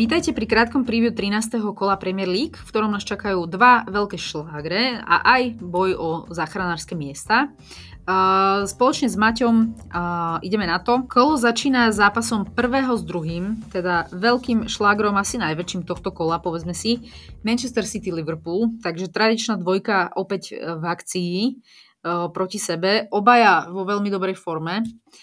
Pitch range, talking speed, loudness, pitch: 180-230 Hz, 145 wpm, -21 LUFS, 205 Hz